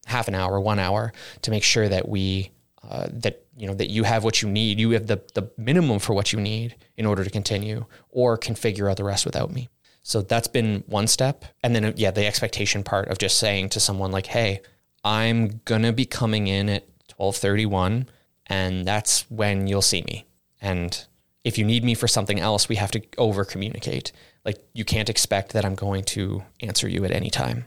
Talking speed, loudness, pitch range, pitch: 210 wpm, -23 LUFS, 100-115 Hz, 105 Hz